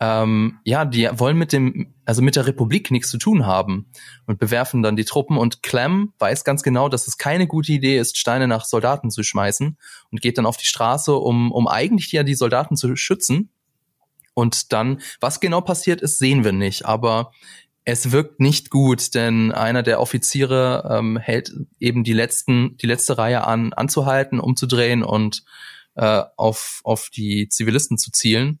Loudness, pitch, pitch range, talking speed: -19 LUFS, 125 Hz, 115-140 Hz, 180 wpm